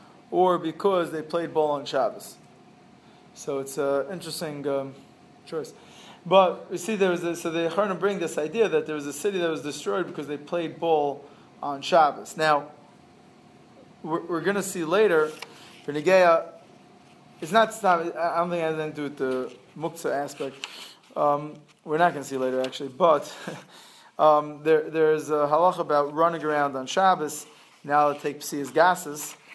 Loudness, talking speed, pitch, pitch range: -25 LUFS, 185 wpm, 155 Hz, 145-175 Hz